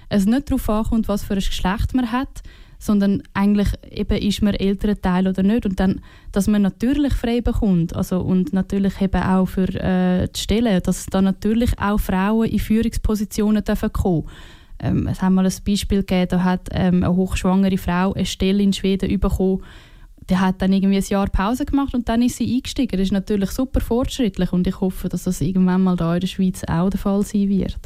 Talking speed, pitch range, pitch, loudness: 205 wpm, 185-215 Hz, 195 Hz, -20 LUFS